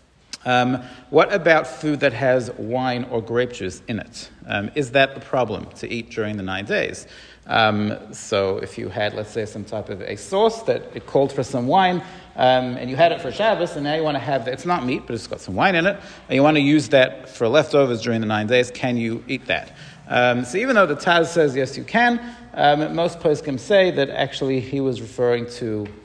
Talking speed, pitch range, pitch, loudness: 230 wpm, 115-150 Hz, 130 Hz, -21 LUFS